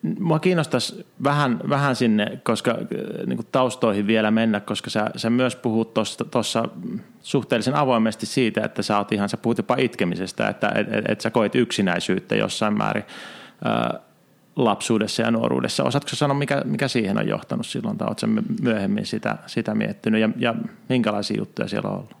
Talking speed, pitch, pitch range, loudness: 150 wpm, 120 Hz, 110-140 Hz, -23 LUFS